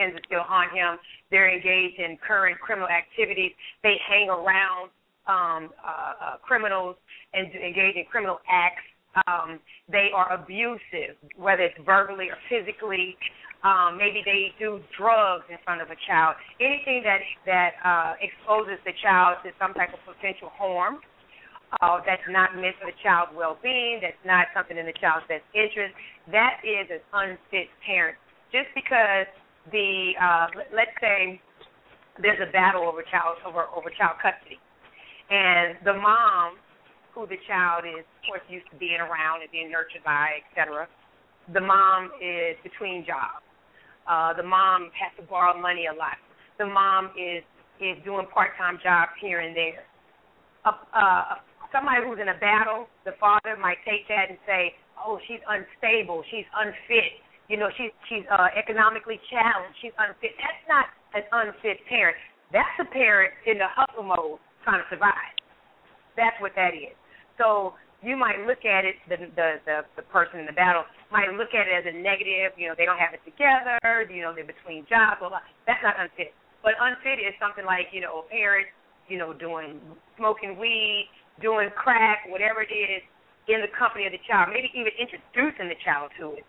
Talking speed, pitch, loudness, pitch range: 175 wpm, 190 Hz, -24 LUFS, 175-215 Hz